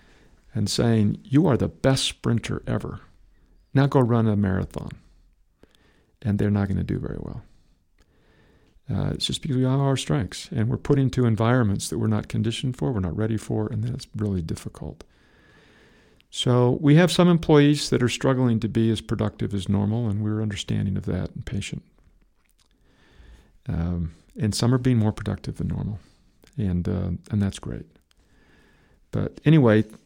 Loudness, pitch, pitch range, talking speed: -23 LUFS, 110 Hz, 100-125 Hz, 170 wpm